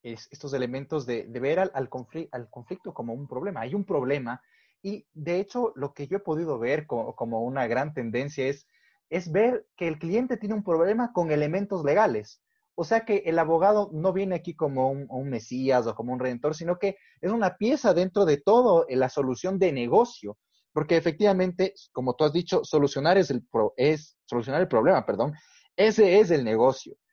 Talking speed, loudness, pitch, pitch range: 200 wpm, -26 LUFS, 165 Hz, 130-195 Hz